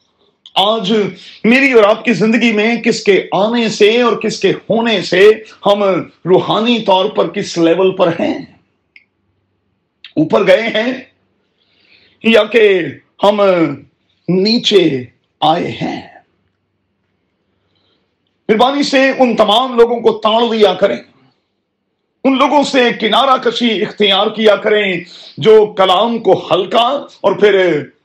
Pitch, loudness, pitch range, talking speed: 210 Hz, -12 LUFS, 180-230 Hz, 120 wpm